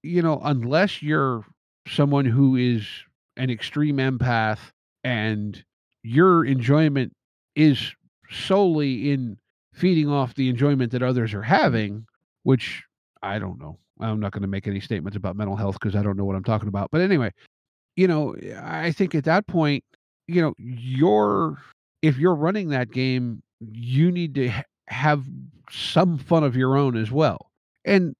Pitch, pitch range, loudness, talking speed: 130 Hz, 110-155 Hz, -23 LUFS, 160 wpm